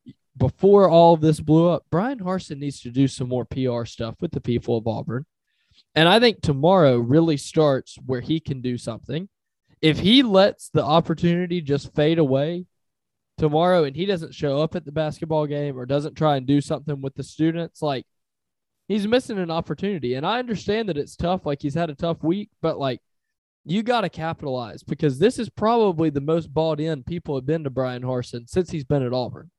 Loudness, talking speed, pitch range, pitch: -22 LUFS, 205 wpm, 140-175 Hz, 155 Hz